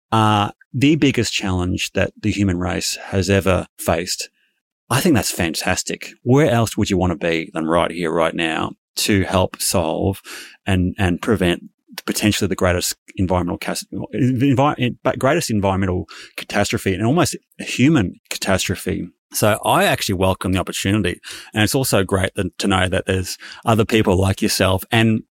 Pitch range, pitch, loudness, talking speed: 90-110 Hz, 100 Hz, -19 LUFS, 155 wpm